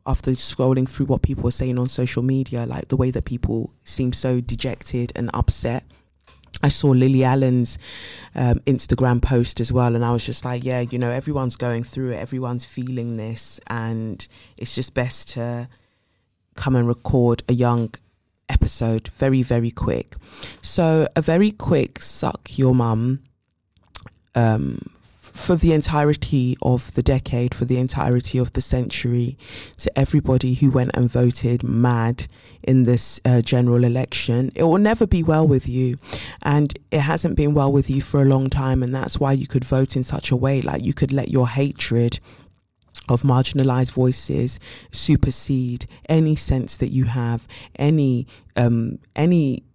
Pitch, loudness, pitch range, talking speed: 125 Hz, -20 LUFS, 120-135 Hz, 165 wpm